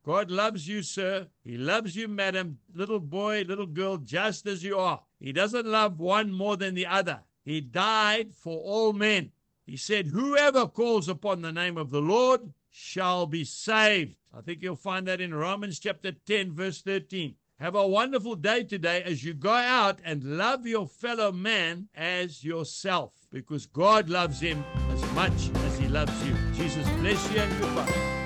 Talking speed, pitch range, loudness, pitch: 180 wpm, 165-210 Hz, -28 LUFS, 190 Hz